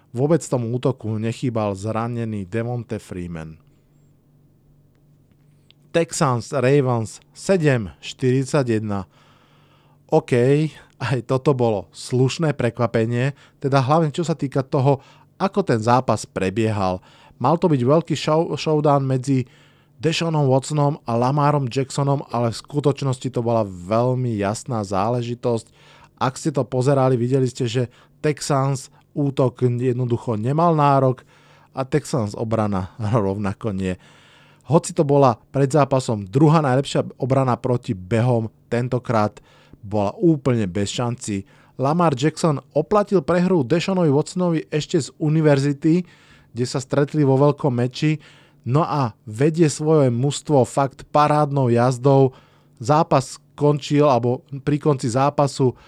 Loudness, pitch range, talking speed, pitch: -20 LUFS, 120-150 Hz, 115 wpm, 135 Hz